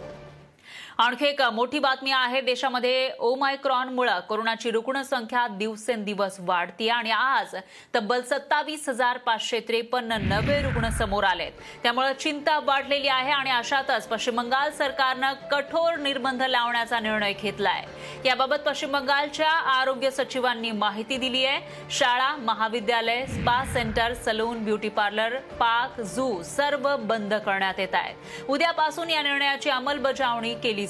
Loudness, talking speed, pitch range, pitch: -25 LUFS, 120 wpm, 230-275 Hz, 255 Hz